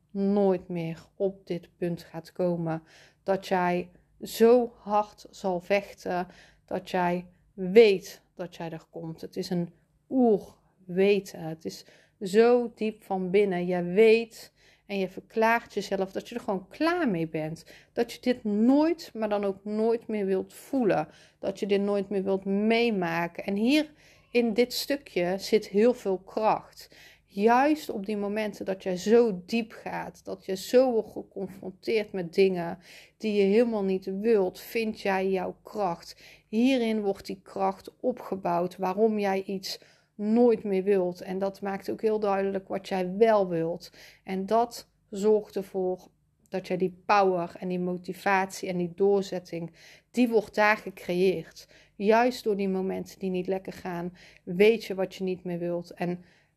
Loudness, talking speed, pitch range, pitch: -27 LUFS, 160 wpm, 180-215 Hz, 195 Hz